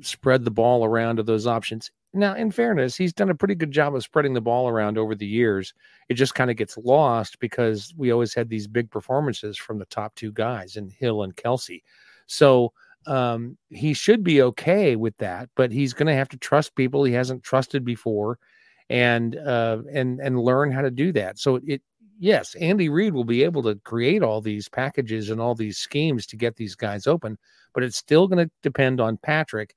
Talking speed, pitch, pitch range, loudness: 210 wpm, 125 Hz, 110-140 Hz, -23 LUFS